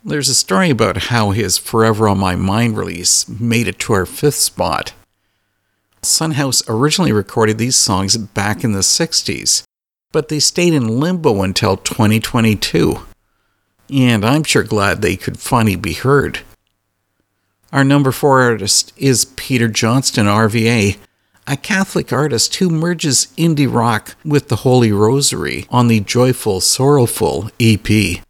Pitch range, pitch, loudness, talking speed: 100-135 Hz, 115 Hz, -14 LUFS, 140 wpm